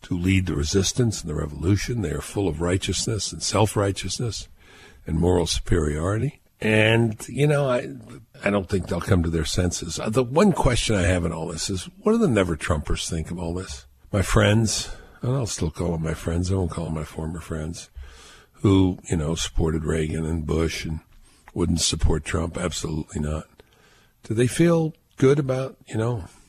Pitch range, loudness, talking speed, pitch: 80-110 Hz, -24 LUFS, 190 wpm, 90 Hz